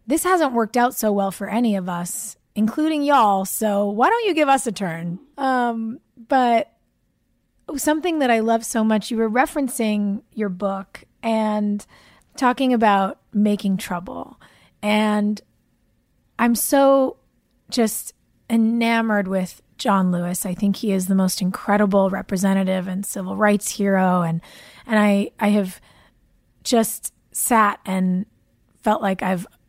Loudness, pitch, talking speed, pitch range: -20 LUFS, 210 Hz, 135 wpm, 195-235 Hz